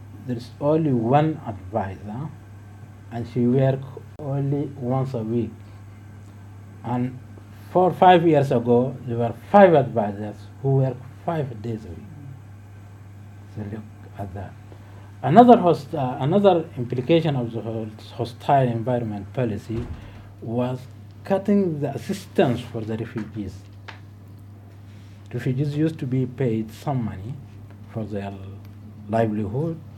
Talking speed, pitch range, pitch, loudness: 115 wpm, 100-130 Hz, 115 Hz, -22 LUFS